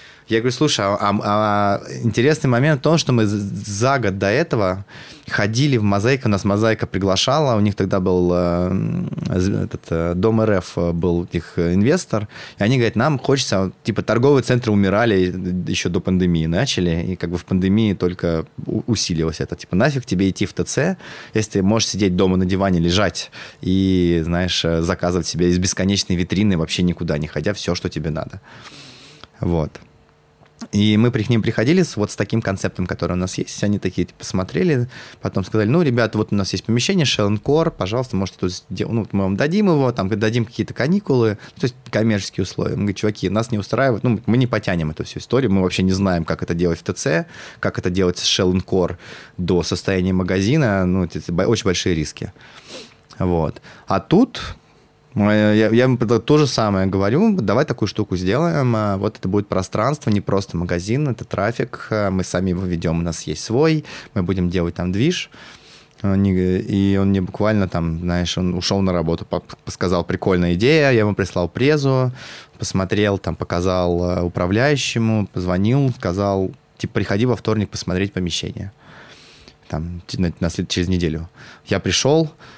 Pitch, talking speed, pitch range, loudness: 100 Hz, 170 wpm, 90-115 Hz, -19 LUFS